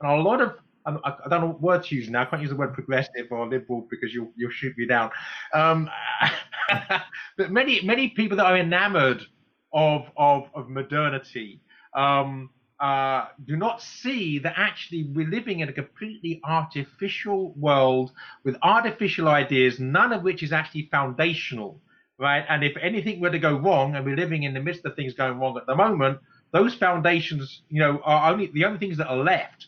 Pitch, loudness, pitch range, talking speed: 150 Hz, -24 LUFS, 135-180 Hz, 190 wpm